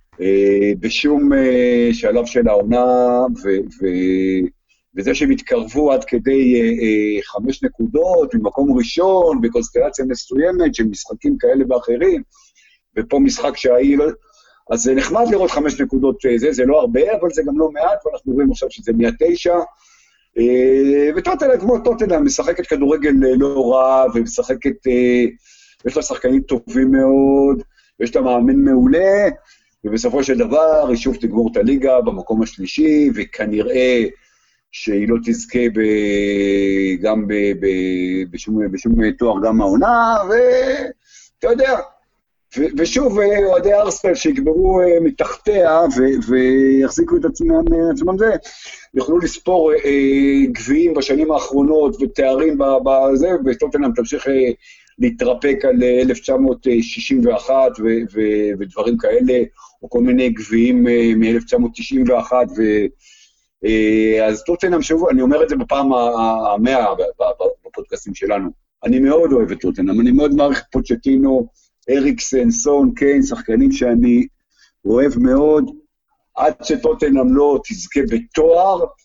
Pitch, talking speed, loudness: 140 Hz, 125 wpm, -15 LUFS